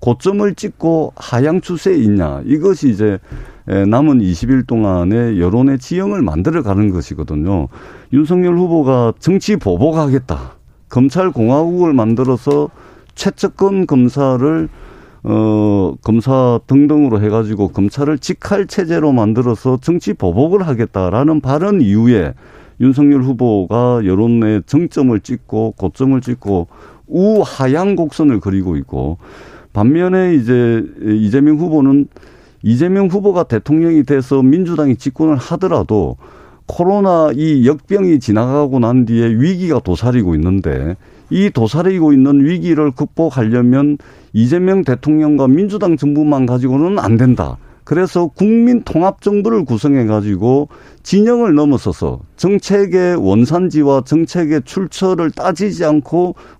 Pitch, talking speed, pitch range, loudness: 140 Hz, 285 characters per minute, 115-170 Hz, -13 LUFS